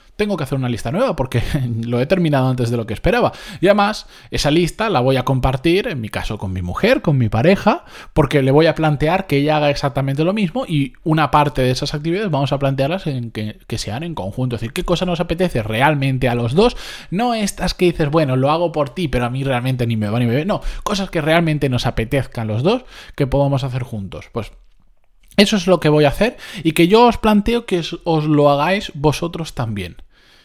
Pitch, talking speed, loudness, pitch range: 150 Hz, 235 wpm, -17 LUFS, 125-175 Hz